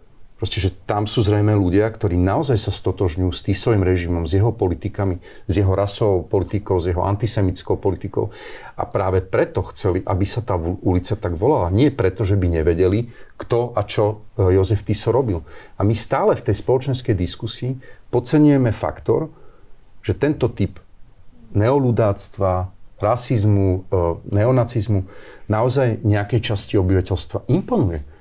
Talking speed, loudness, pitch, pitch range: 140 wpm, -20 LUFS, 105 Hz, 95-115 Hz